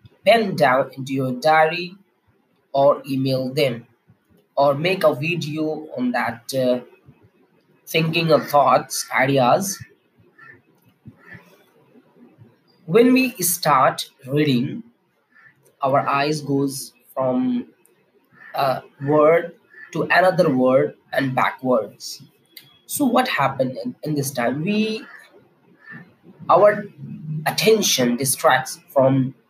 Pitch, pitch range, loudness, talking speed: 150 Hz, 130-180 Hz, -19 LUFS, 95 wpm